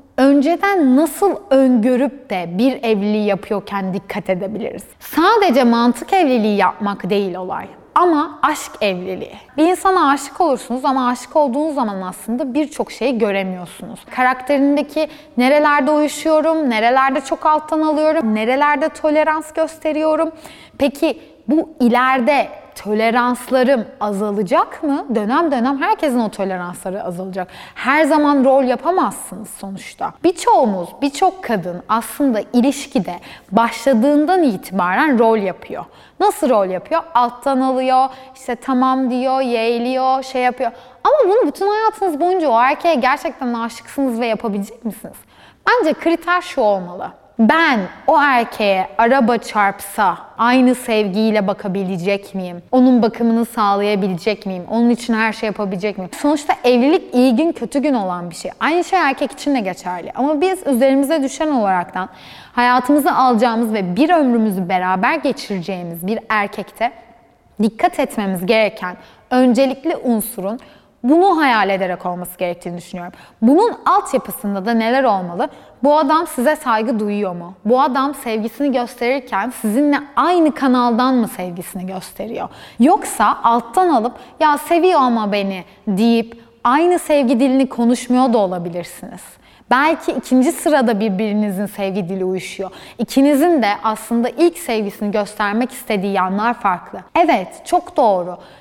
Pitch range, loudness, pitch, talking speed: 205-290 Hz, -16 LUFS, 245 Hz, 125 wpm